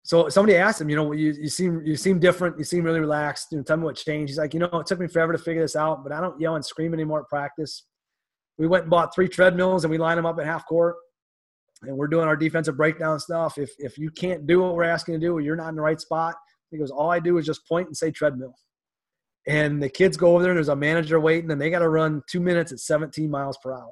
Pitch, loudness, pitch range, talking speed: 160 Hz, -23 LUFS, 150-170 Hz, 290 wpm